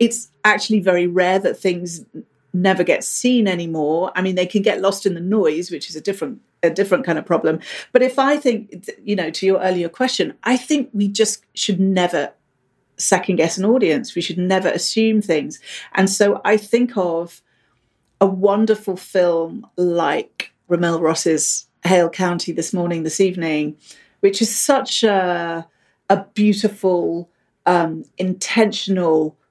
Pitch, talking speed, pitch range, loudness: 185 Hz, 155 wpm, 170-210 Hz, -18 LUFS